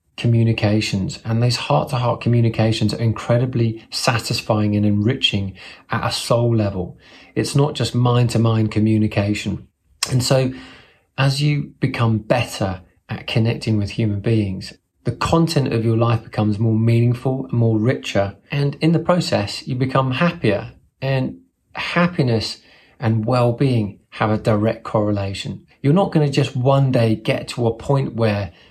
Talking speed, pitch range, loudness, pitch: 140 wpm, 110-130 Hz, -19 LUFS, 115 Hz